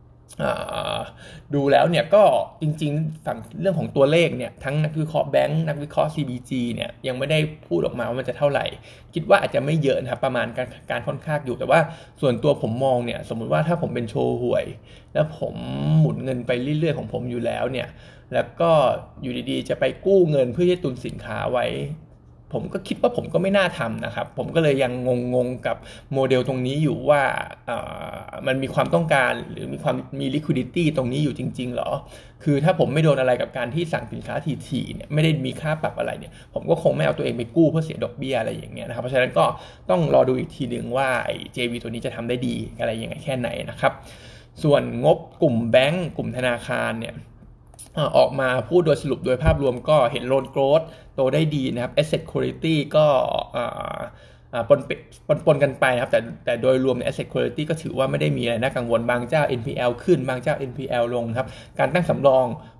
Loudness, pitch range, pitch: -22 LUFS, 120-155 Hz, 135 Hz